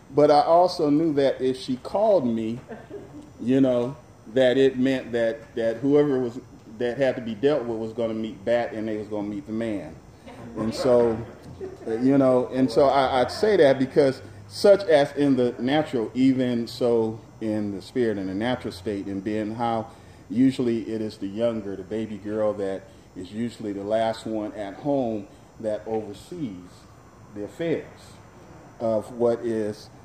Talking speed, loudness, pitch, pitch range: 175 wpm, -24 LUFS, 115 Hz, 110-130 Hz